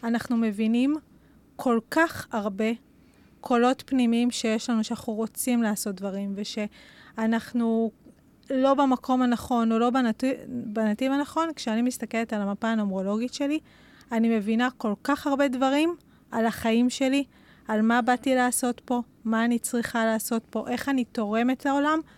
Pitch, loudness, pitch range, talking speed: 235 Hz, -26 LUFS, 225-260 Hz, 140 wpm